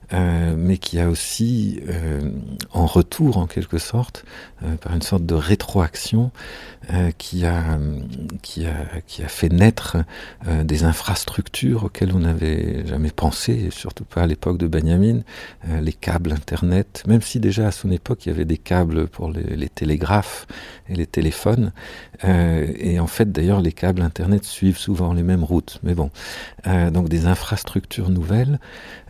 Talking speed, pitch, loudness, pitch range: 170 wpm, 85 Hz, -21 LUFS, 80-95 Hz